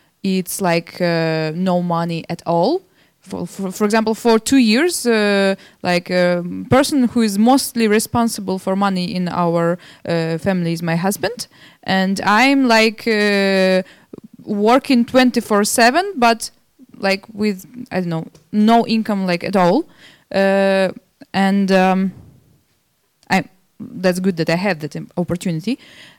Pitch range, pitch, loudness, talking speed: 180-230 Hz, 195 Hz, -17 LUFS, 140 wpm